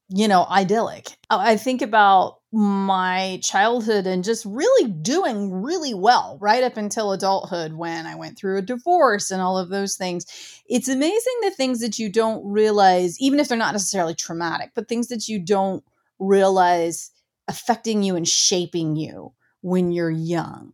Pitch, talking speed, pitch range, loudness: 200 Hz, 165 wpm, 180-230 Hz, -21 LUFS